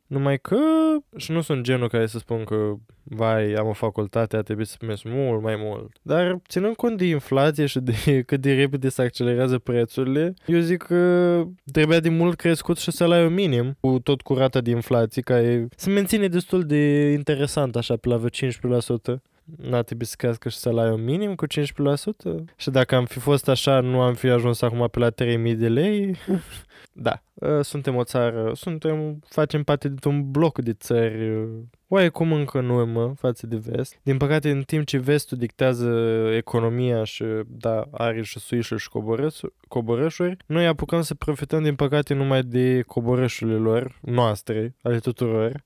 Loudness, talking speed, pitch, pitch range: -23 LUFS, 175 wpm, 130 Hz, 115-150 Hz